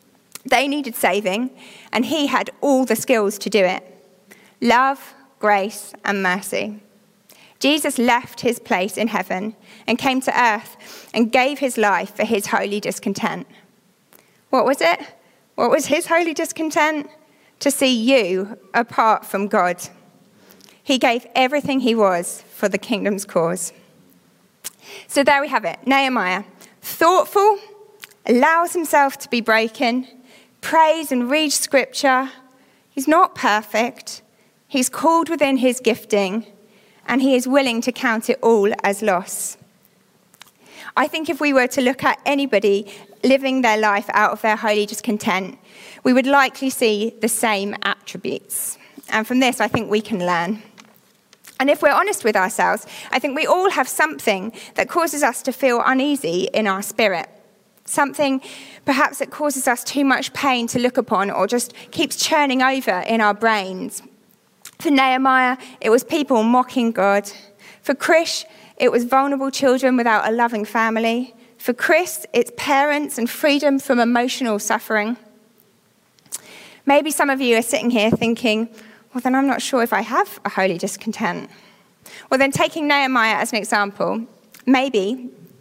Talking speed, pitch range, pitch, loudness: 150 wpm, 215-275 Hz, 235 Hz, -19 LUFS